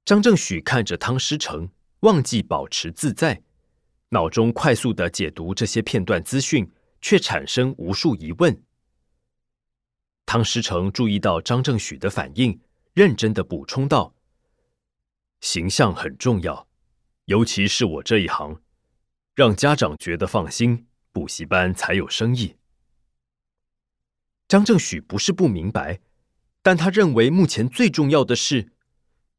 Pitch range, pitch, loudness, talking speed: 95-135 Hz, 115 Hz, -21 LUFS, 200 characters per minute